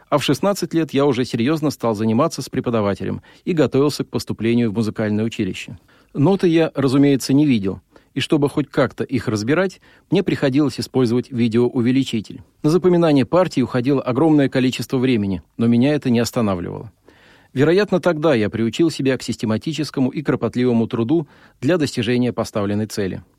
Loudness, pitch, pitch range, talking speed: -19 LUFS, 130 Hz, 115-150 Hz, 150 wpm